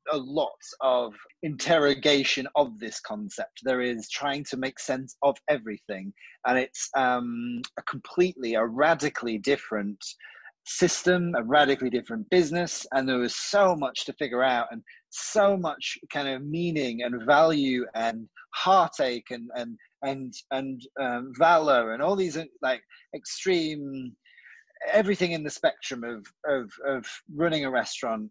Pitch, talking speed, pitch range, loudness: 135 Hz, 140 wpm, 120-165 Hz, -27 LUFS